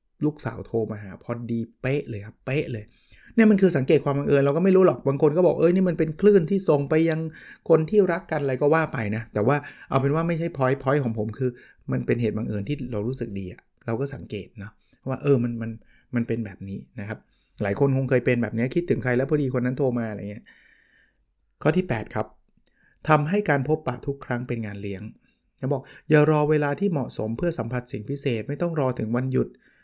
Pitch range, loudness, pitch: 115-150 Hz, -24 LUFS, 130 Hz